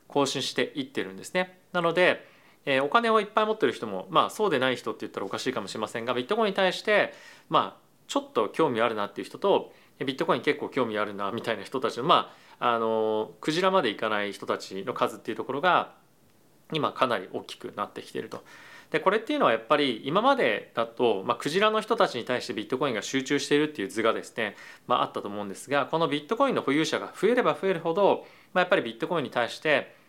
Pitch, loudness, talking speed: 160 Hz, -27 LUFS, 470 characters per minute